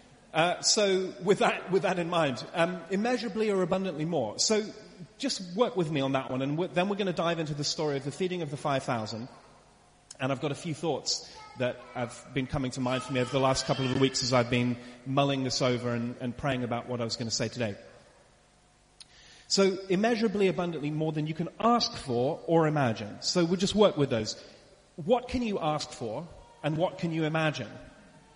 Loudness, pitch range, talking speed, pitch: -29 LUFS, 130-185 Hz, 215 wpm, 155 Hz